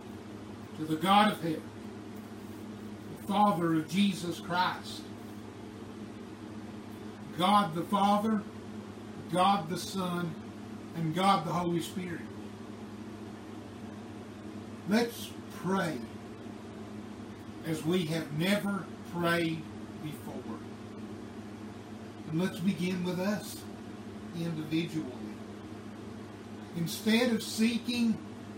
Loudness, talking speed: -31 LUFS, 80 wpm